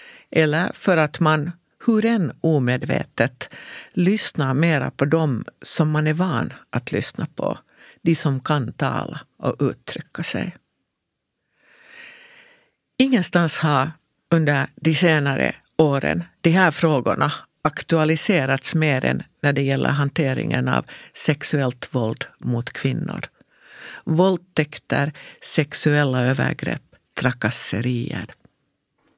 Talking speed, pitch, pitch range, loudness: 105 wpm, 155 Hz, 140-175 Hz, -21 LUFS